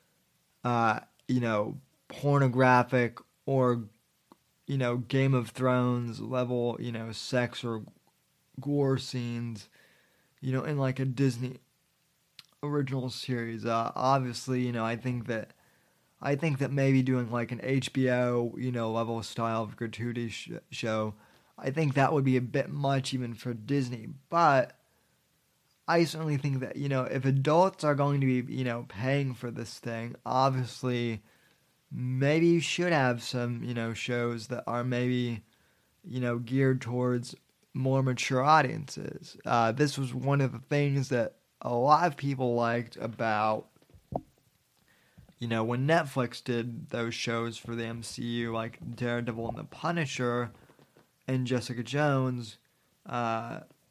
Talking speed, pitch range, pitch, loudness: 145 wpm, 120-135 Hz, 125 Hz, -30 LUFS